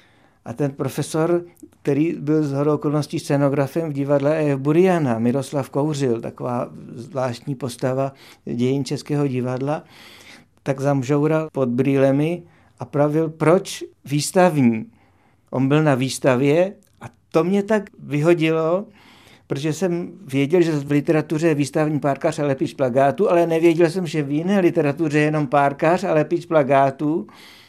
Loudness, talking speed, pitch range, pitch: -20 LUFS, 135 wpm, 135-165 Hz, 145 Hz